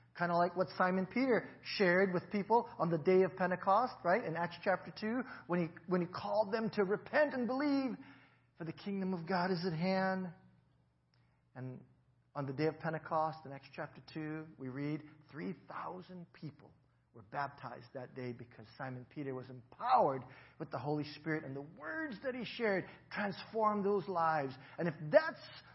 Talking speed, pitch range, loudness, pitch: 175 wpm, 140-190 Hz, -36 LUFS, 170 Hz